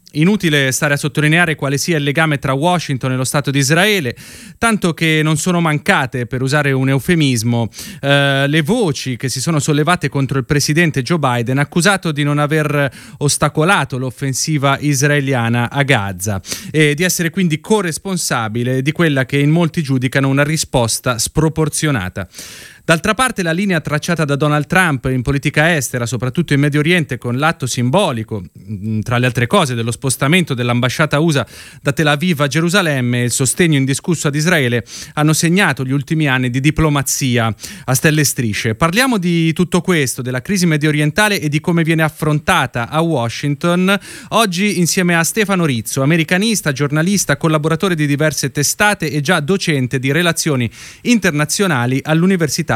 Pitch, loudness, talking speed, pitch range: 150 Hz, -15 LUFS, 160 wpm, 135-170 Hz